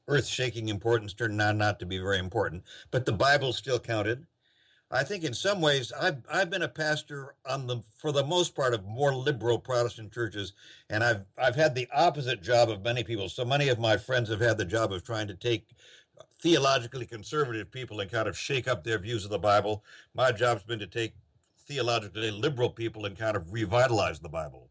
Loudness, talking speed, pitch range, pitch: -29 LUFS, 205 wpm, 110-135 Hz, 120 Hz